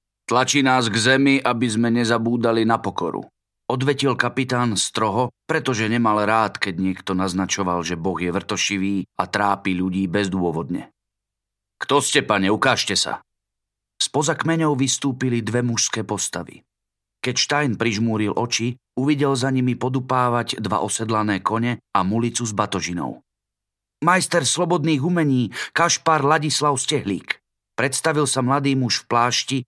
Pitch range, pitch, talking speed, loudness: 100-135 Hz, 115 Hz, 130 wpm, -20 LUFS